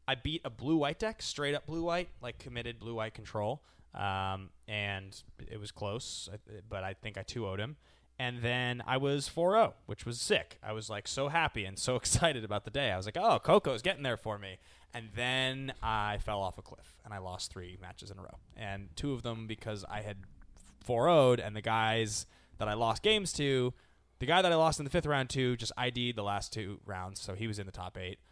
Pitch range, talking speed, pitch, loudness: 100-130 Hz, 230 wpm, 110 Hz, -34 LUFS